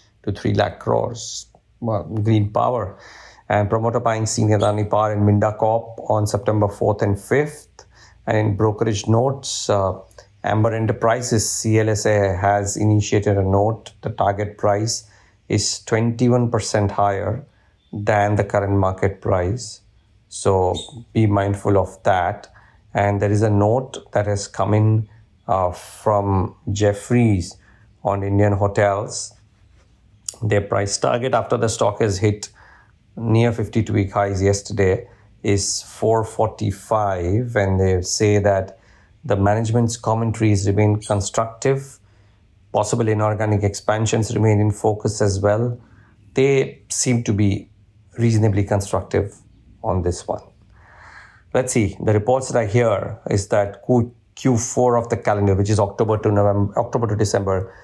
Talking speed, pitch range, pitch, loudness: 130 wpm, 100-110 Hz, 105 Hz, -20 LUFS